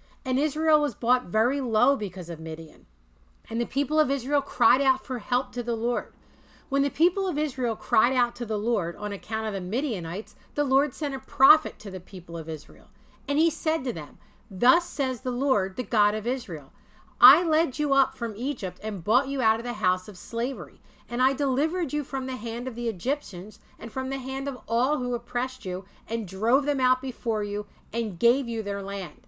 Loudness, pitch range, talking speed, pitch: -26 LUFS, 210-270 Hz, 215 wpm, 240 Hz